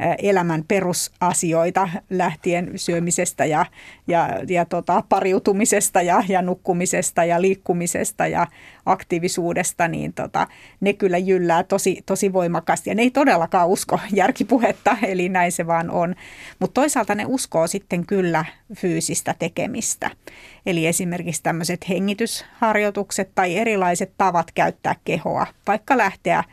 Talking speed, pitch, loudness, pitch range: 120 wpm, 185 Hz, -20 LUFS, 175-200 Hz